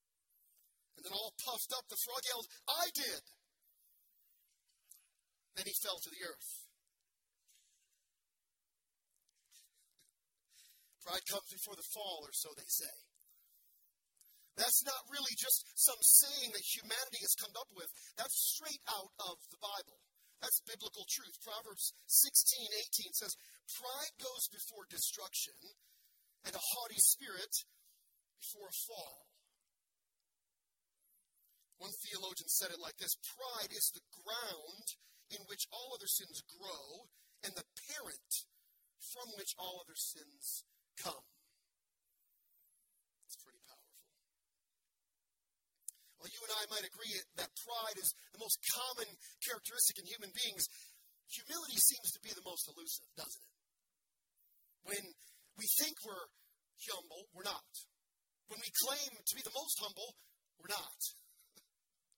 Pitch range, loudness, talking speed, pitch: 205-270 Hz, -37 LUFS, 125 wpm, 230 Hz